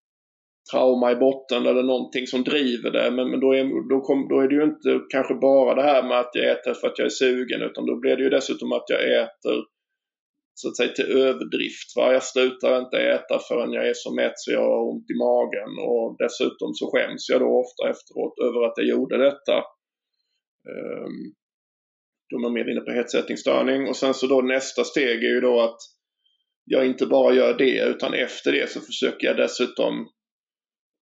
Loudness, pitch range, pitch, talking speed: -22 LUFS, 120-135 Hz, 130 Hz, 200 wpm